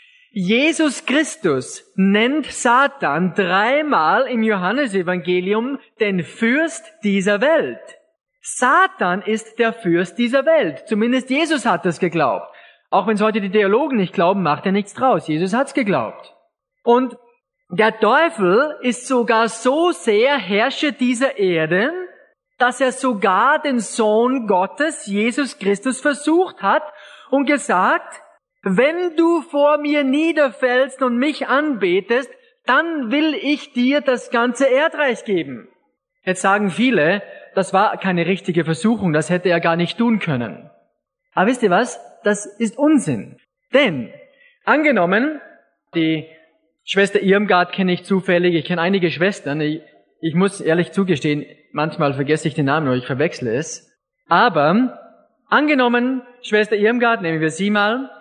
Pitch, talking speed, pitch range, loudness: 230 Hz, 135 wpm, 185-290 Hz, -18 LUFS